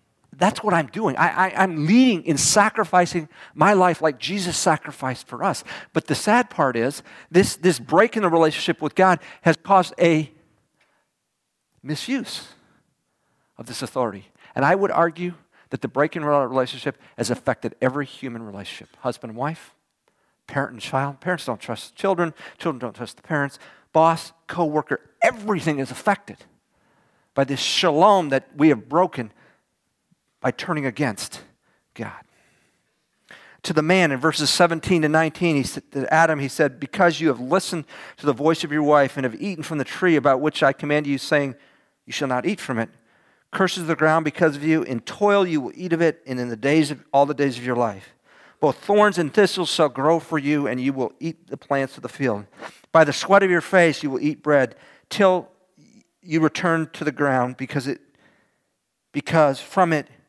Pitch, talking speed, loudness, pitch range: 155 Hz, 190 wpm, -21 LUFS, 140-175 Hz